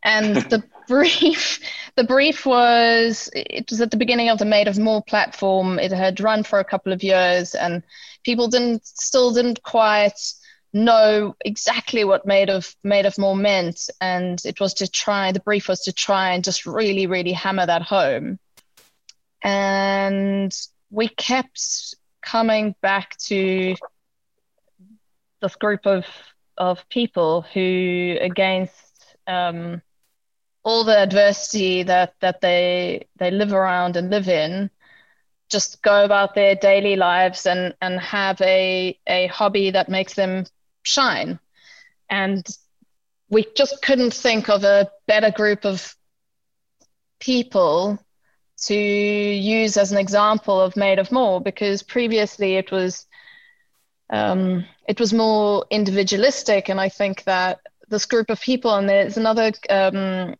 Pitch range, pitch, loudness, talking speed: 190-220 Hz, 200 Hz, -19 LUFS, 140 wpm